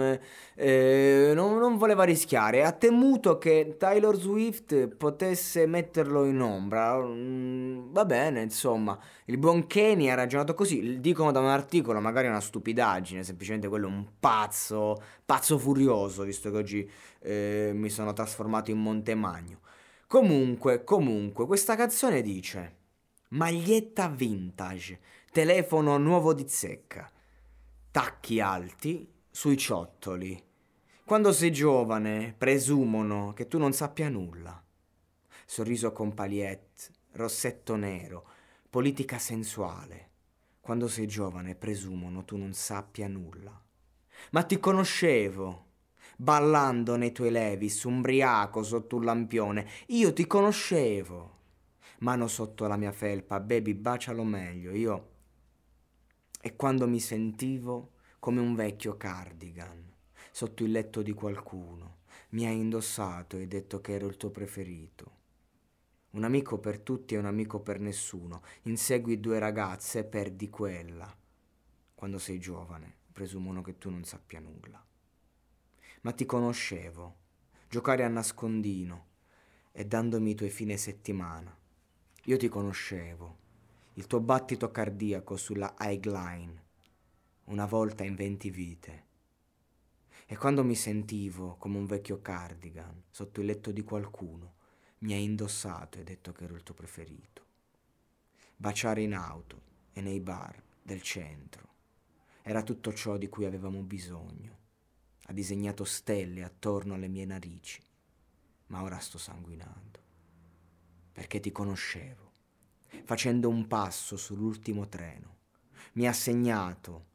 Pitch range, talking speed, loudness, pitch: 95-120 Hz, 125 wpm, -29 LUFS, 105 Hz